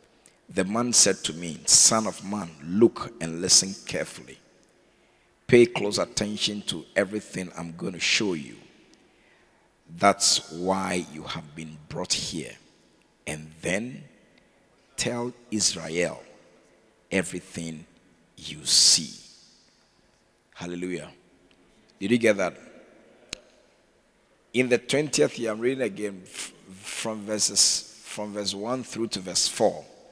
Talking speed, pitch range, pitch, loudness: 115 wpm, 90-115 Hz, 100 Hz, -24 LUFS